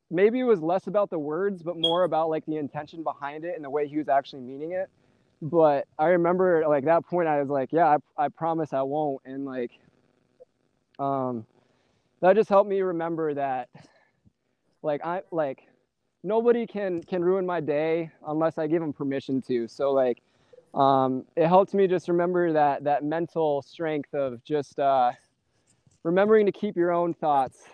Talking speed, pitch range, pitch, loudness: 180 wpm, 140-175 Hz, 160 Hz, -25 LUFS